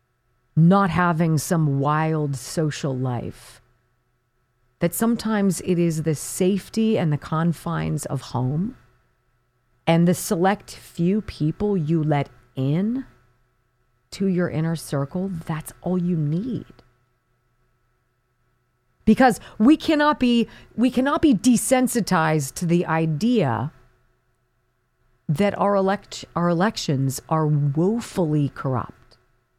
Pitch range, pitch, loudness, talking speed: 120-185 Hz, 155 Hz, -22 LUFS, 105 wpm